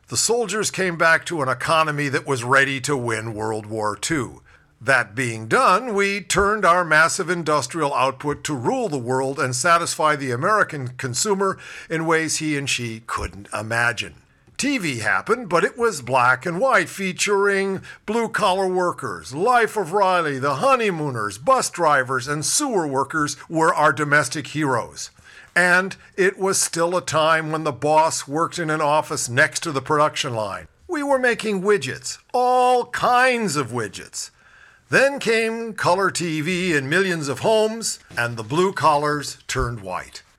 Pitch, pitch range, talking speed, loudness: 160 Hz, 135-195 Hz, 155 wpm, -20 LUFS